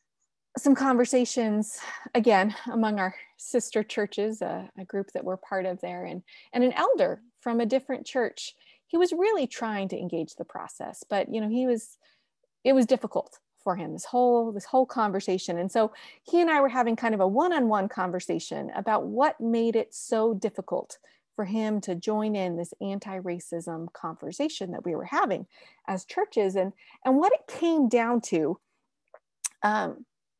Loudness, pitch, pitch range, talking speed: -27 LUFS, 225 Hz, 195-260 Hz, 175 wpm